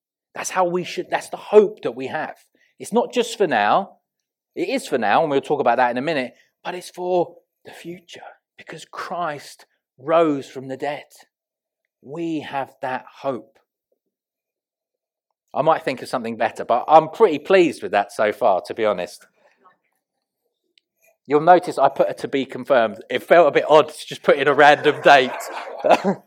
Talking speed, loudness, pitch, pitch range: 180 wpm, -19 LUFS, 175 Hz, 155-230 Hz